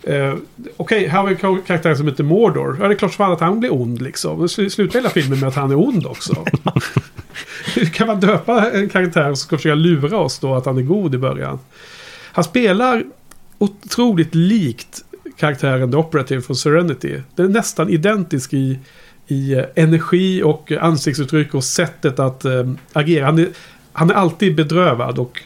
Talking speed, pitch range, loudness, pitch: 185 wpm, 140-195 Hz, -17 LUFS, 165 Hz